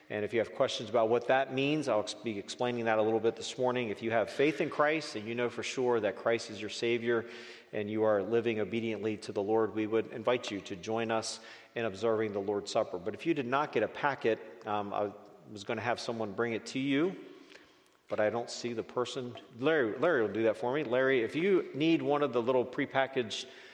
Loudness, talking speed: -32 LUFS, 240 wpm